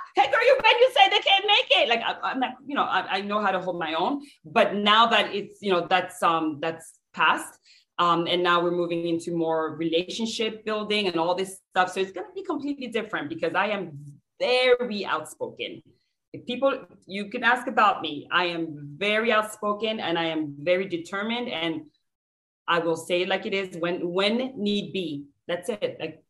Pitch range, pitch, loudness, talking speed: 170-230 Hz, 190 Hz, -24 LUFS, 205 wpm